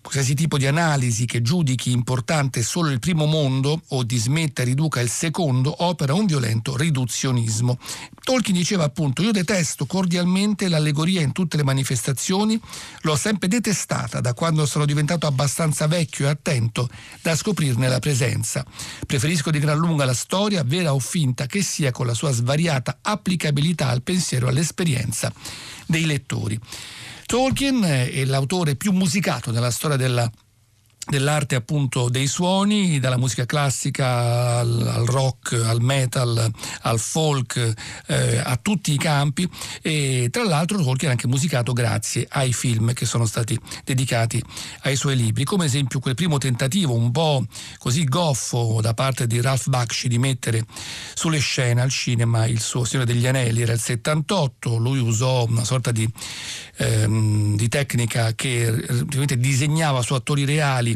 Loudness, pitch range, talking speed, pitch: -21 LUFS, 120-155 Hz, 155 wpm, 135 Hz